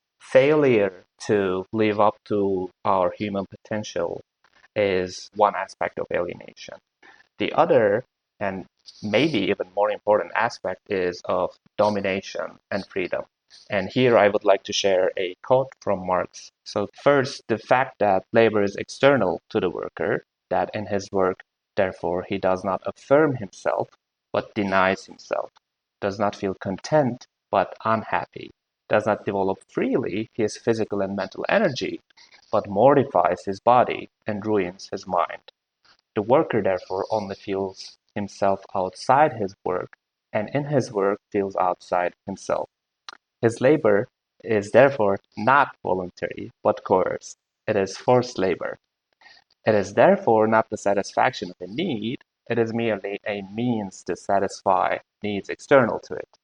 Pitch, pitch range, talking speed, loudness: 100 Hz, 95-110 Hz, 140 wpm, -23 LUFS